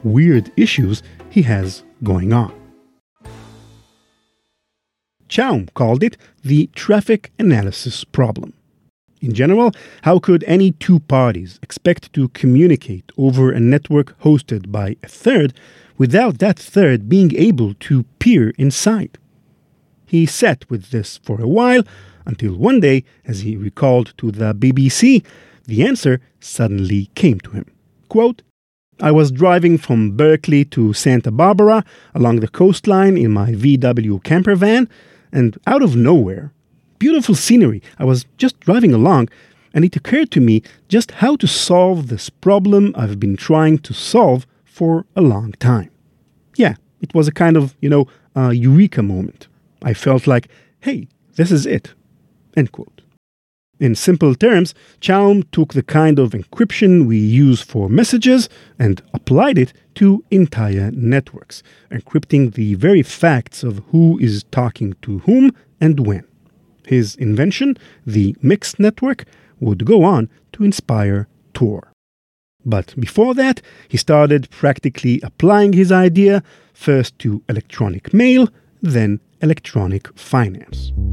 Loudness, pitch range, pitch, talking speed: -14 LUFS, 115-180 Hz, 140 Hz, 140 wpm